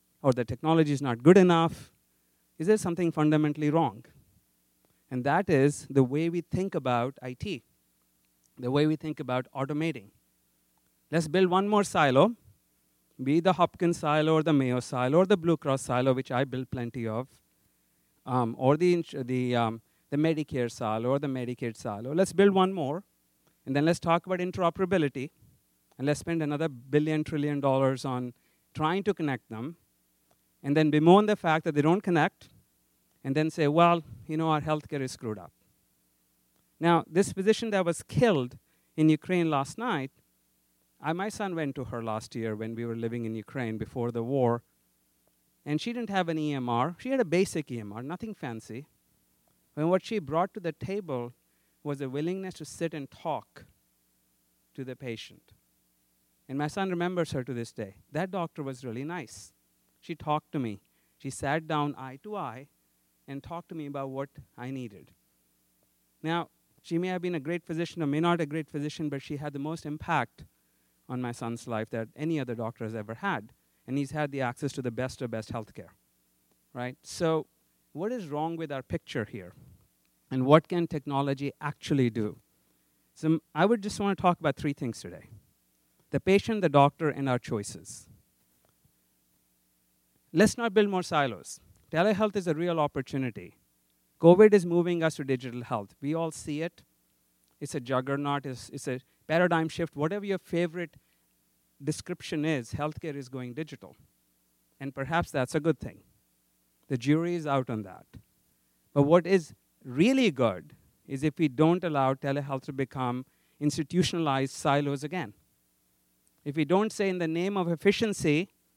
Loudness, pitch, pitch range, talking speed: -29 LUFS, 140 Hz, 110-165 Hz, 175 wpm